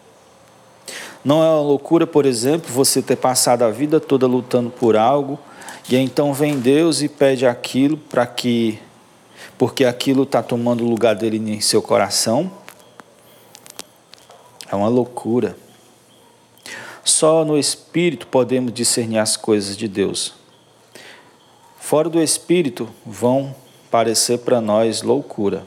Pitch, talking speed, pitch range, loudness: 125 Hz, 125 wpm, 115-145 Hz, -17 LUFS